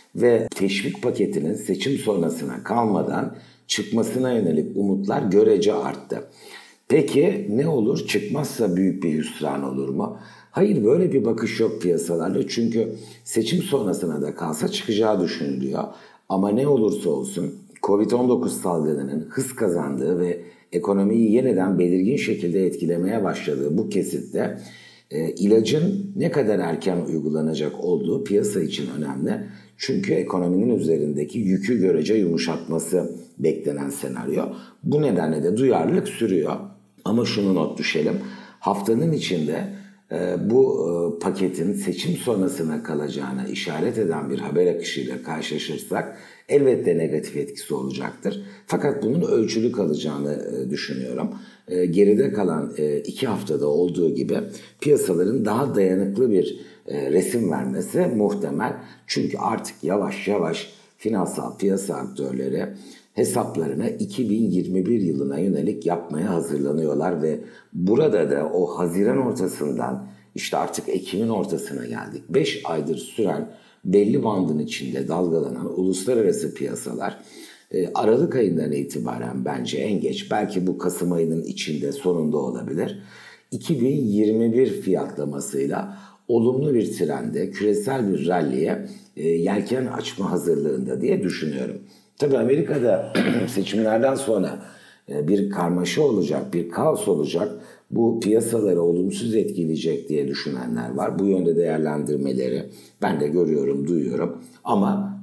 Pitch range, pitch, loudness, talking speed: 75-120 Hz, 95 Hz, -23 LUFS, 110 wpm